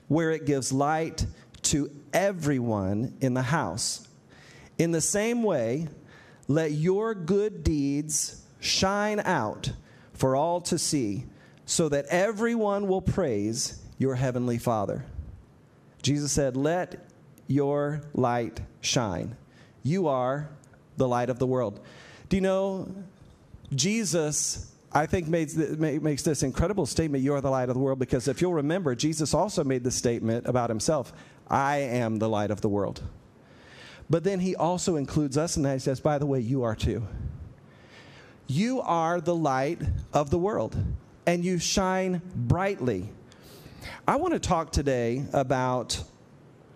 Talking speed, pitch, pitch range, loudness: 145 wpm, 145 Hz, 125-170 Hz, -27 LUFS